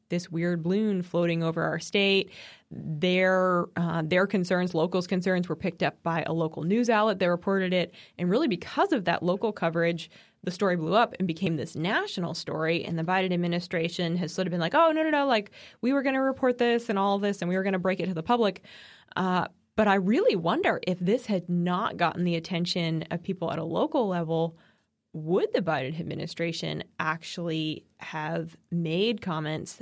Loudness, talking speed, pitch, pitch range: -27 LUFS, 200 wpm, 180 Hz, 165-195 Hz